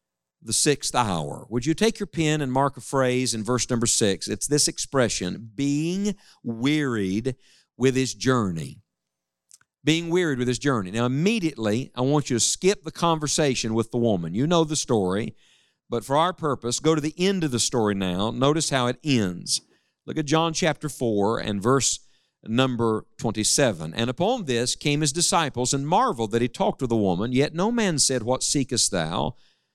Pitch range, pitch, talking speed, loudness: 115-155 Hz, 130 Hz, 185 wpm, -23 LUFS